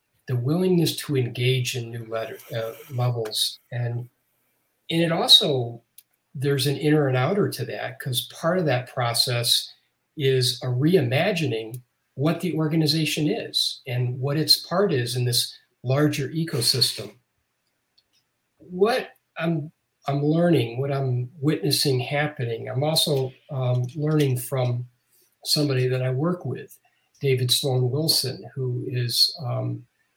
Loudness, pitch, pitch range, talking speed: -23 LUFS, 130 Hz, 125-150 Hz, 130 wpm